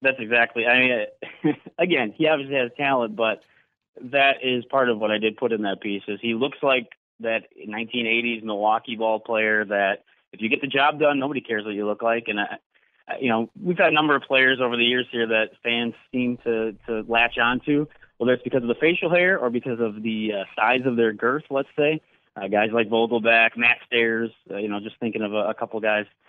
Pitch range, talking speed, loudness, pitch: 110-135 Hz, 225 wpm, -22 LUFS, 115 Hz